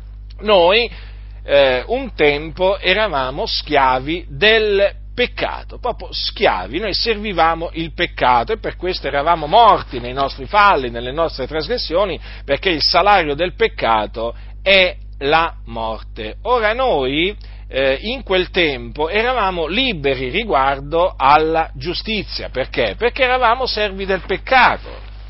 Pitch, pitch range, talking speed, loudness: 165 Hz, 130-210 Hz, 120 wpm, -17 LUFS